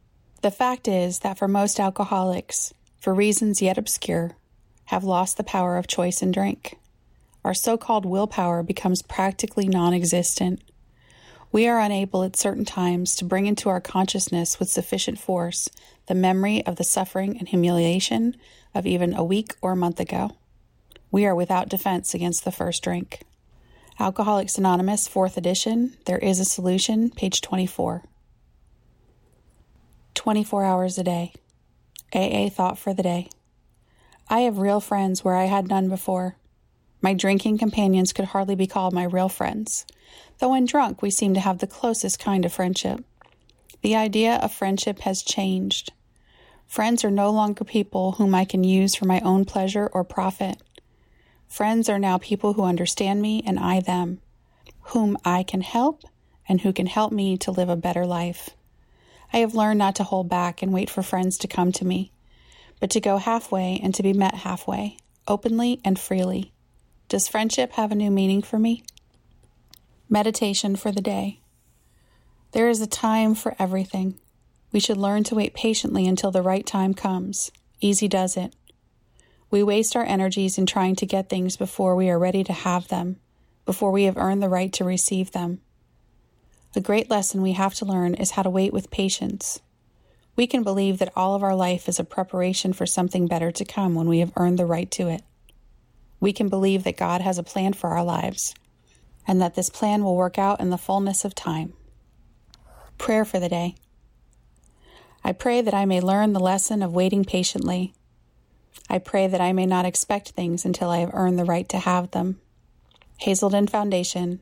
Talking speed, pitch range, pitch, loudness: 175 wpm, 180-205 Hz, 190 Hz, -23 LUFS